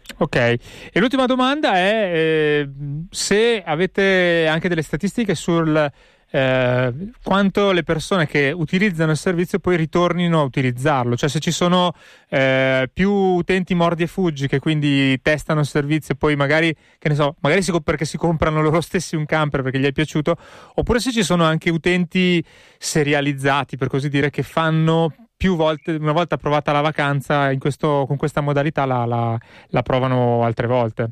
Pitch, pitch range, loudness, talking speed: 155 Hz, 140-175 Hz, -19 LUFS, 170 wpm